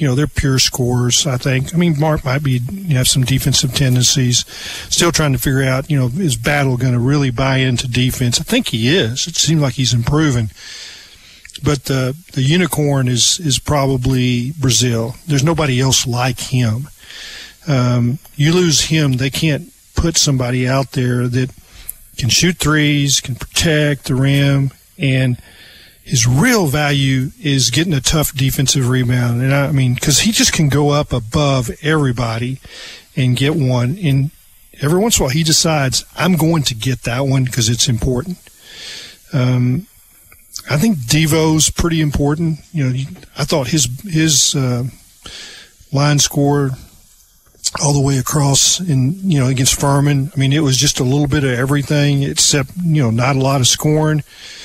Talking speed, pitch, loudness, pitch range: 170 wpm, 135 Hz, -15 LUFS, 125-150 Hz